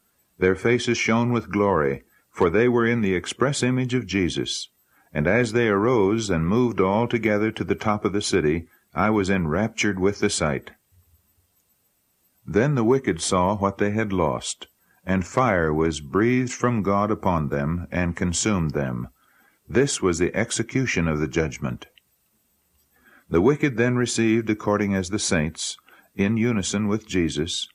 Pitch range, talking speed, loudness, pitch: 90-115 Hz, 155 wpm, -23 LUFS, 100 Hz